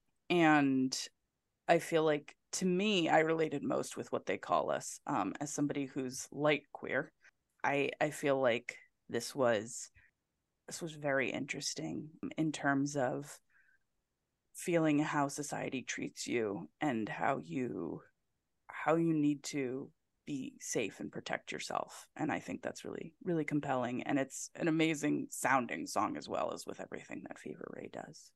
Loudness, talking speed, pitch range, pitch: -35 LUFS, 150 wpm, 140-160 Hz, 150 Hz